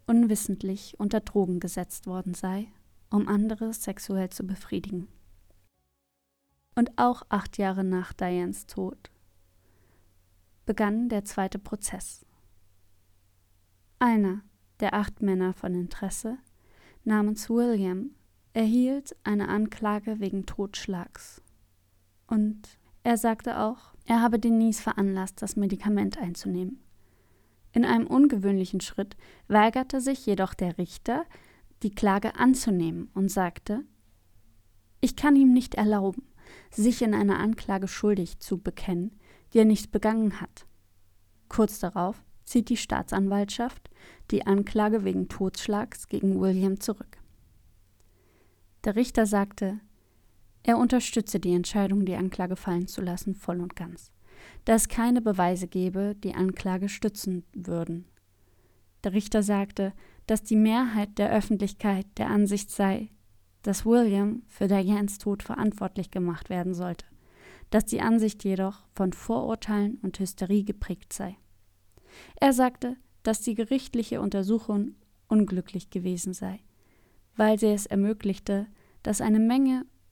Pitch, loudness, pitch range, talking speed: 195 Hz, -27 LUFS, 175-215 Hz, 120 wpm